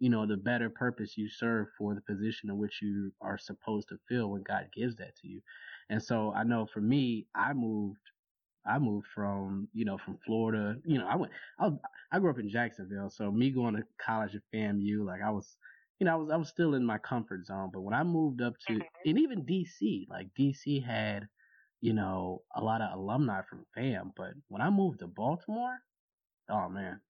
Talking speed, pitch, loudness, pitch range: 215 wpm, 110 Hz, -34 LUFS, 105-125 Hz